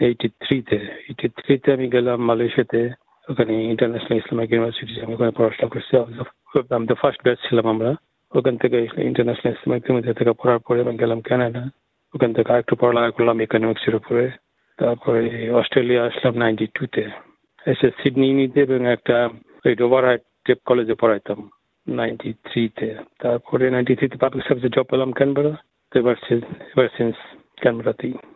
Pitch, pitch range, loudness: 120 Hz, 115-130 Hz, -20 LUFS